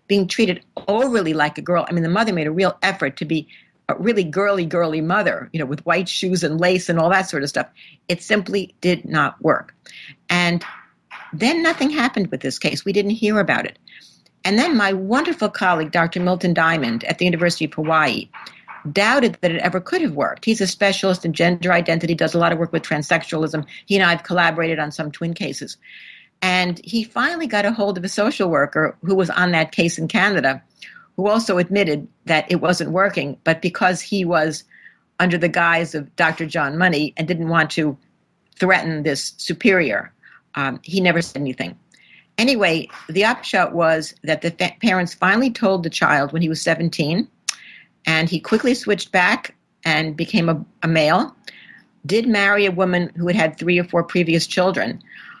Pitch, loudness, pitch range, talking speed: 175 Hz, -19 LUFS, 160-200 Hz, 195 wpm